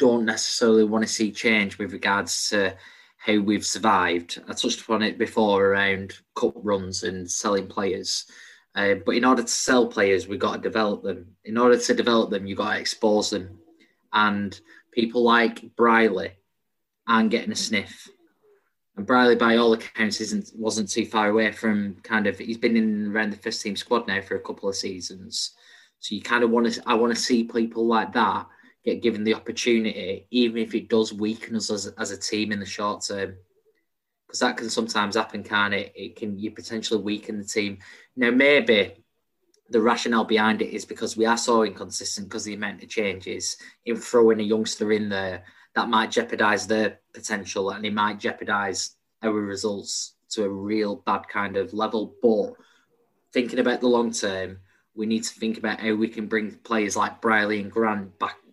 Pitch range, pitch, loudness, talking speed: 100-115 Hz, 110 Hz, -24 LUFS, 190 wpm